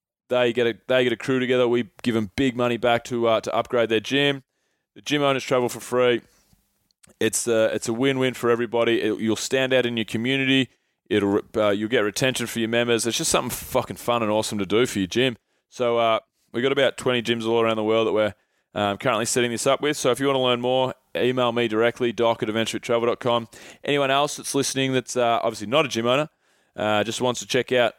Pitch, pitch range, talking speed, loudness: 120 Hz, 115-130 Hz, 240 wpm, -22 LUFS